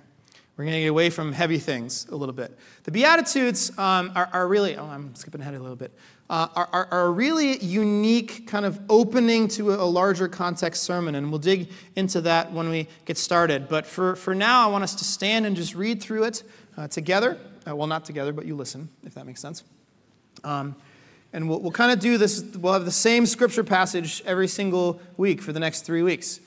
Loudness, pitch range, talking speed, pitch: -23 LUFS, 160-205 Hz, 220 wpm, 180 Hz